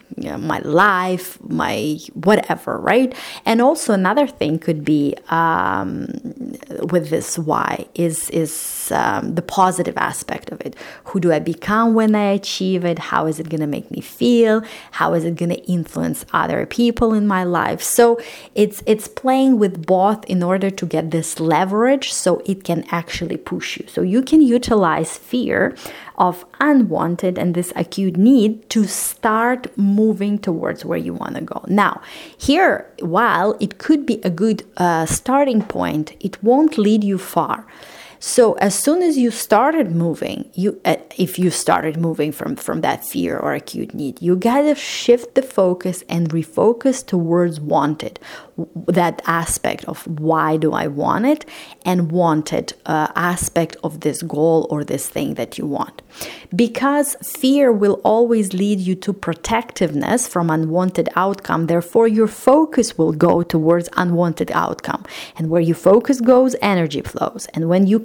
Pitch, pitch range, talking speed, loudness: 185 Hz, 170-230 Hz, 165 wpm, -18 LUFS